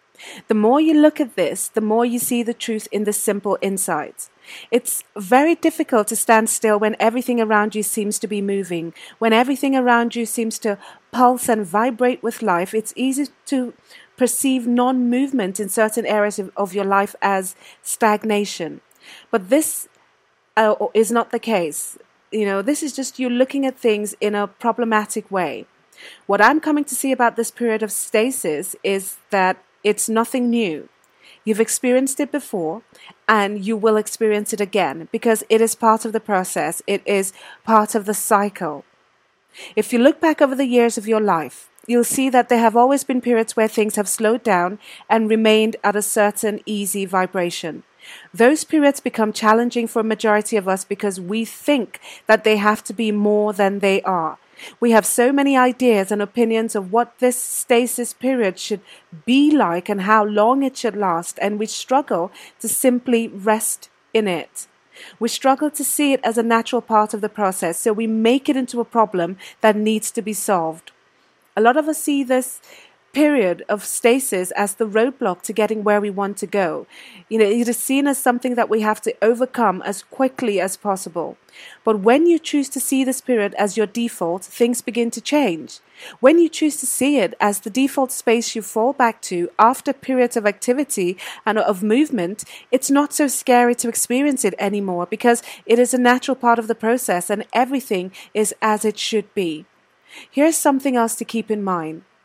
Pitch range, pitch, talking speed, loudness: 210-250 Hz, 225 Hz, 185 wpm, -19 LUFS